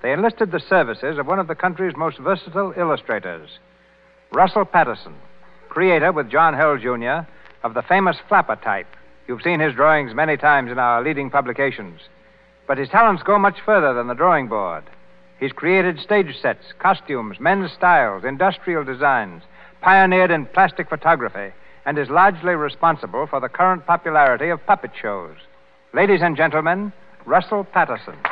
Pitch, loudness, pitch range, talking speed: 170 Hz, -18 LUFS, 145-190 Hz, 155 wpm